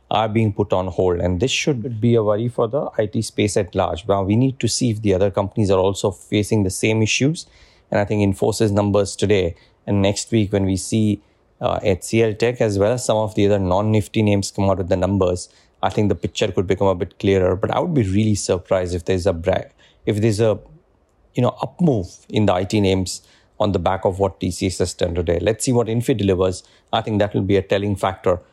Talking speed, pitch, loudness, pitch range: 240 wpm, 105 Hz, -20 LUFS, 95-110 Hz